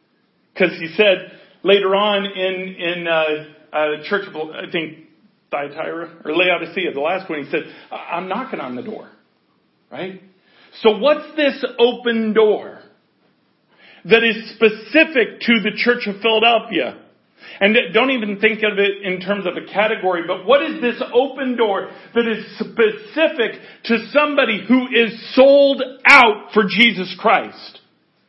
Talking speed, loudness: 150 wpm, -17 LUFS